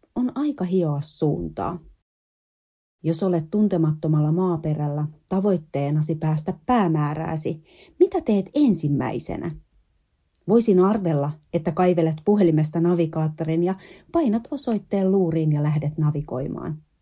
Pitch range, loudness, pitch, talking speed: 150-195 Hz, -22 LUFS, 165 Hz, 95 wpm